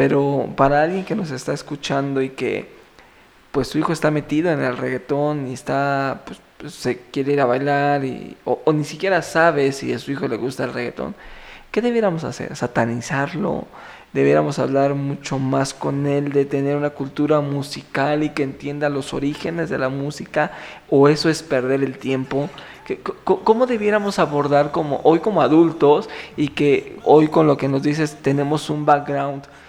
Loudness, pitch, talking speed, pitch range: -20 LUFS, 145 Hz, 180 wpm, 135-155 Hz